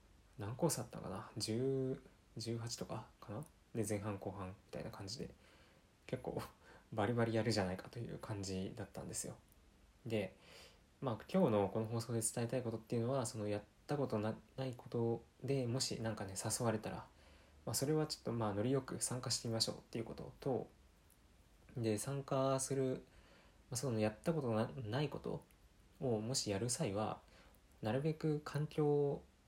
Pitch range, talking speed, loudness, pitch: 105-135 Hz, 320 characters per minute, -41 LUFS, 115 Hz